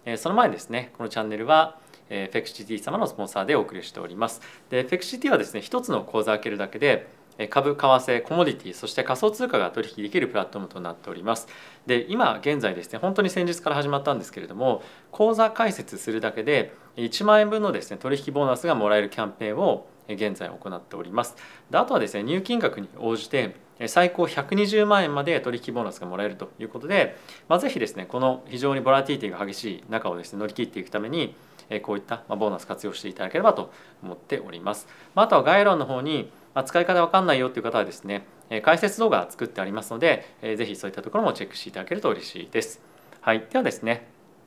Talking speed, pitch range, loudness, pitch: 465 characters per minute, 110-175 Hz, -25 LUFS, 130 Hz